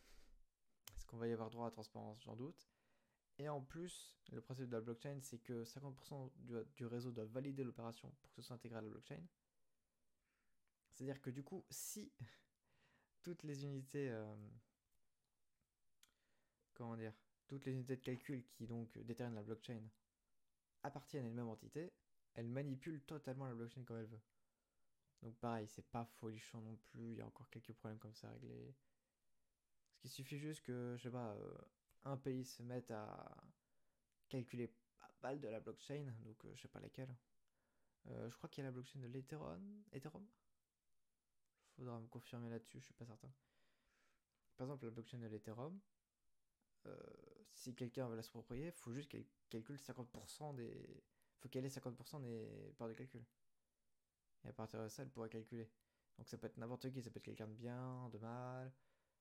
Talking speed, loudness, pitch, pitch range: 185 wpm, -53 LUFS, 120 Hz, 115-135 Hz